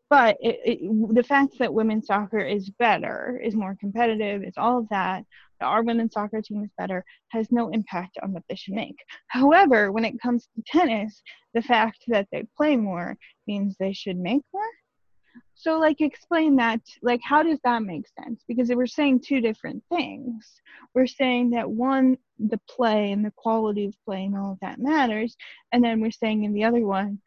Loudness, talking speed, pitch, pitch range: -24 LUFS, 195 wpm, 230 Hz, 210-255 Hz